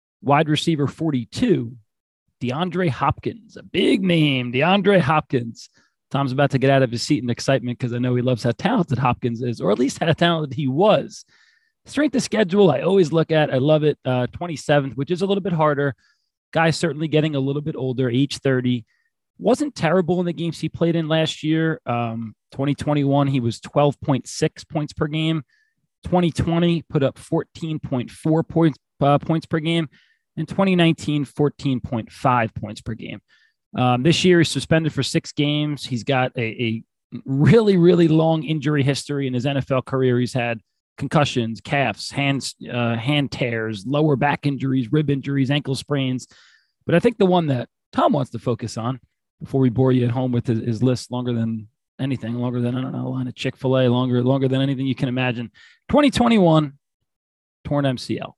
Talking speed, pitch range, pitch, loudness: 190 wpm, 125-160 Hz, 140 Hz, -21 LUFS